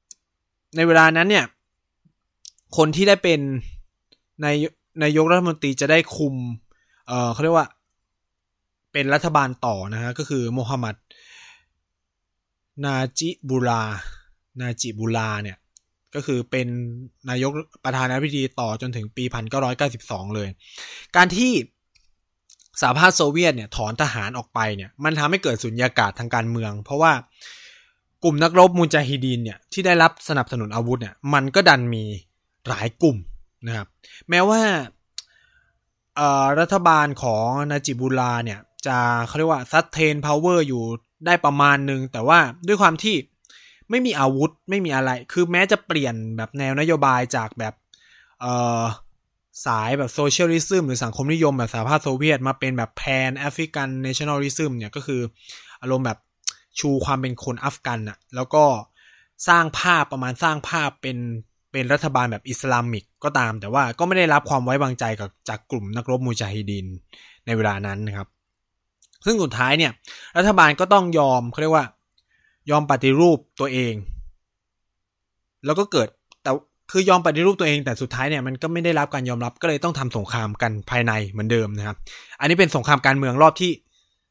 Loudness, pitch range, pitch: -21 LUFS, 110-155 Hz, 130 Hz